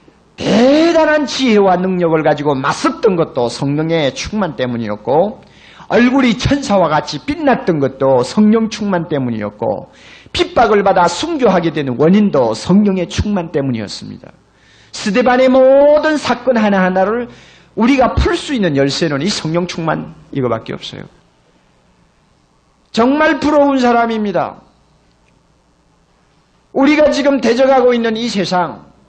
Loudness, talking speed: -13 LUFS, 275 characters per minute